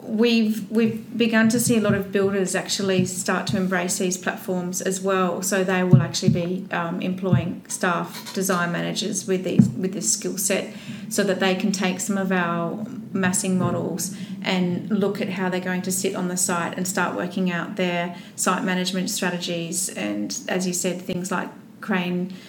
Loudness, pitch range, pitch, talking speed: -23 LUFS, 180-205 Hz, 190 Hz, 185 wpm